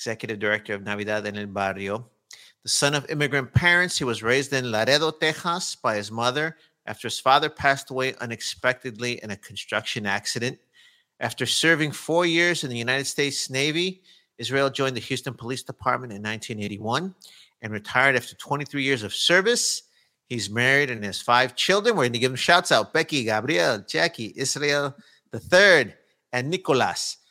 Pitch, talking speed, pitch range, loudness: 130 Hz, 165 wpm, 115-150 Hz, -23 LUFS